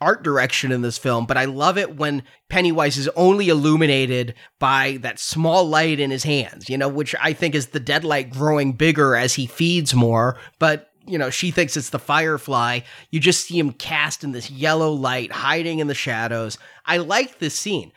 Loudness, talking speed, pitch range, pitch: -20 LUFS, 200 wpm, 130-160 Hz, 145 Hz